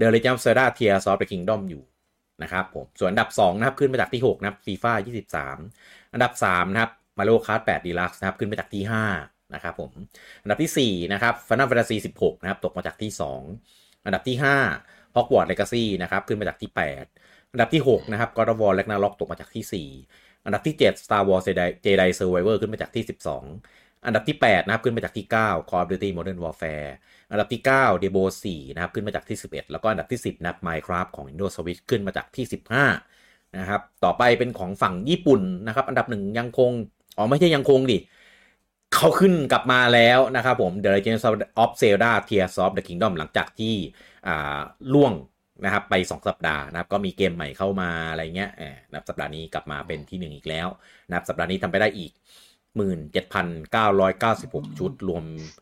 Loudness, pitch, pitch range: -23 LUFS, 100 Hz, 90-115 Hz